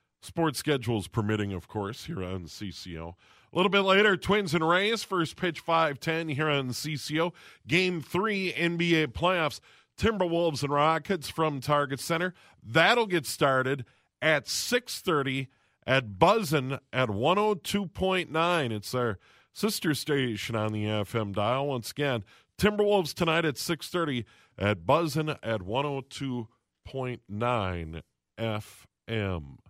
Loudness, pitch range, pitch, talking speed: -28 LUFS, 115-170 Hz, 145 Hz, 120 wpm